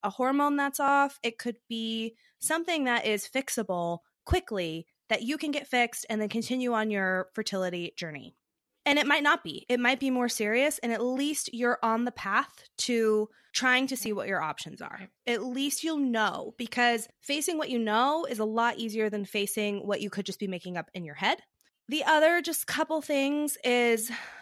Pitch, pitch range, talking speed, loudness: 240 Hz, 215-280 Hz, 195 wpm, -29 LUFS